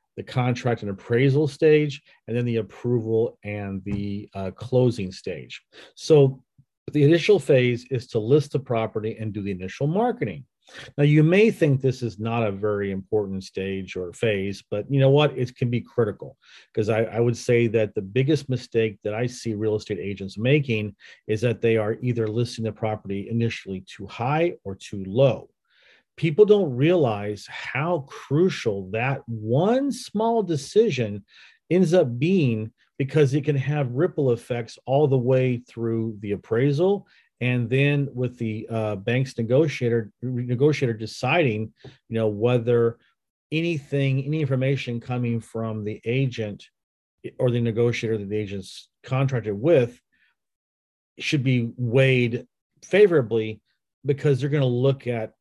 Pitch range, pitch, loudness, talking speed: 110-140 Hz, 120 Hz, -23 LUFS, 150 wpm